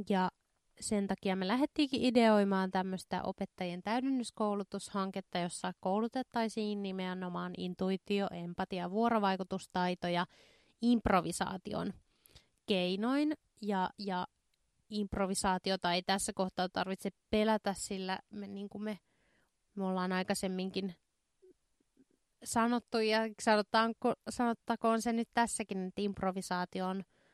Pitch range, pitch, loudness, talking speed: 185-220 Hz, 195 Hz, -35 LUFS, 90 wpm